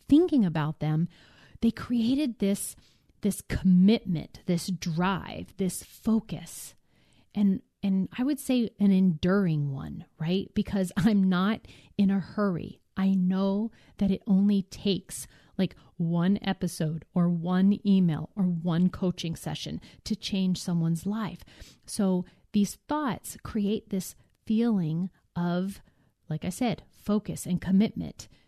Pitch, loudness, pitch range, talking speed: 190 Hz, -28 LUFS, 175-205 Hz, 125 wpm